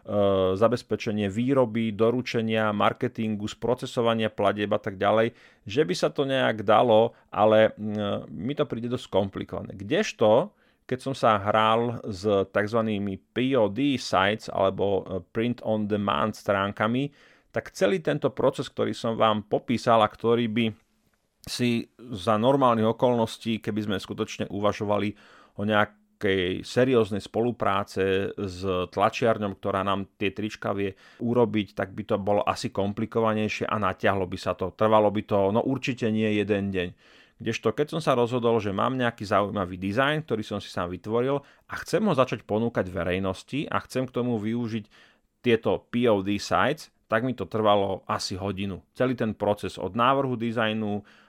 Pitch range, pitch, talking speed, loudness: 100-120 Hz, 110 Hz, 145 wpm, -26 LUFS